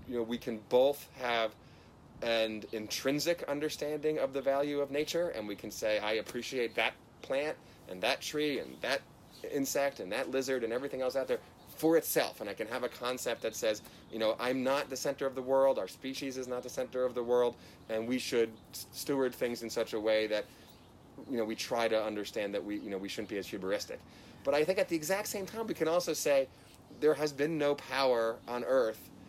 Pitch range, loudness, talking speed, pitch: 110-145 Hz, -34 LUFS, 220 wpm, 130 Hz